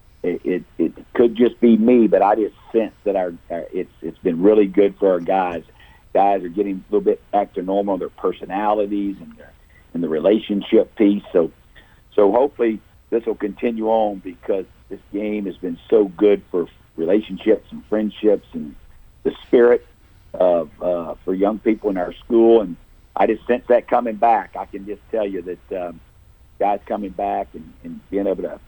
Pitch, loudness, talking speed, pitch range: 105 Hz, -19 LUFS, 185 wpm, 95-110 Hz